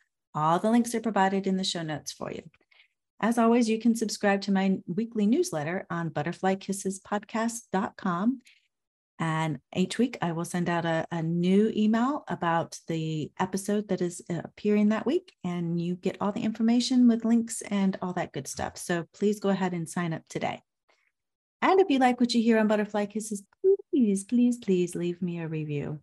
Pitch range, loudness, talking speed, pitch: 170-225 Hz, -27 LUFS, 180 wpm, 195 Hz